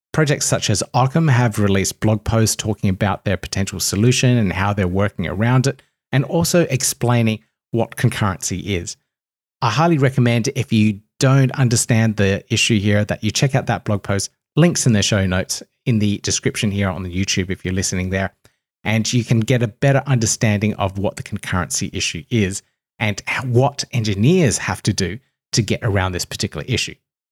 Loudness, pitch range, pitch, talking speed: -18 LUFS, 100-125 Hz, 110 Hz, 180 wpm